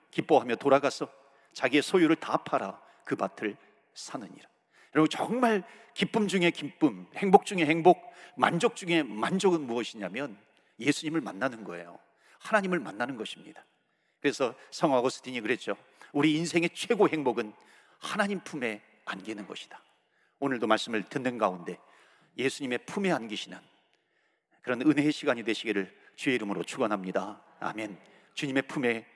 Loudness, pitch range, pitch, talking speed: -29 LUFS, 120-190 Hz, 150 Hz, 325 characters per minute